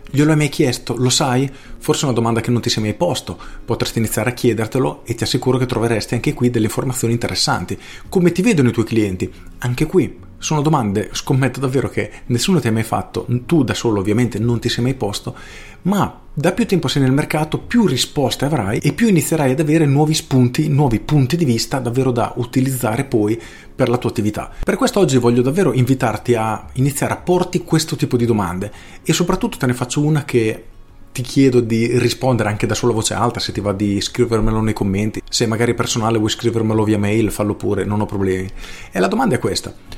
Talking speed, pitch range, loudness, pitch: 210 wpm, 110-140 Hz, -17 LUFS, 120 Hz